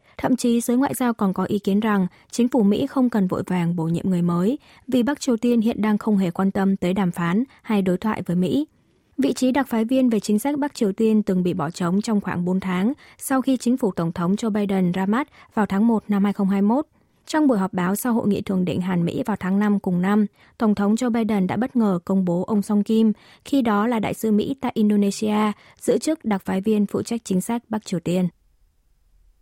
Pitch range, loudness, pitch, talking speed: 185-235 Hz, -22 LUFS, 210 Hz, 245 wpm